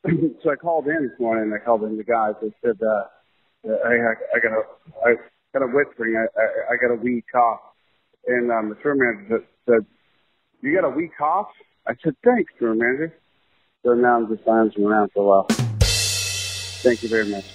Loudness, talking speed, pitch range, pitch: -21 LUFS, 200 wpm, 105-125 Hz, 115 Hz